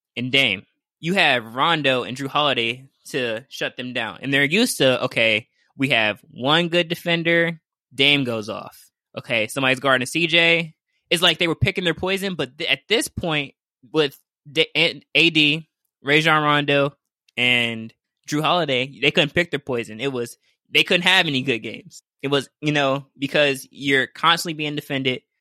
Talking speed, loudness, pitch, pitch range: 170 wpm, -20 LUFS, 140 Hz, 130-165 Hz